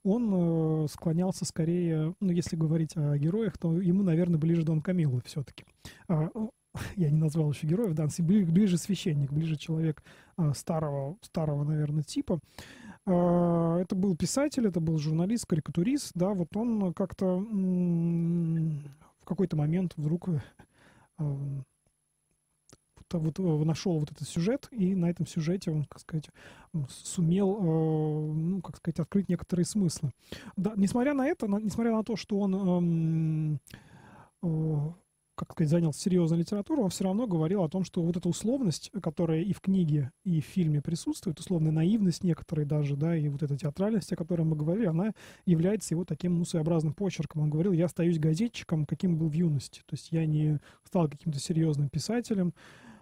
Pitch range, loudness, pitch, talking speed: 155-185 Hz, -30 LUFS, 170 Hz, 150 wpm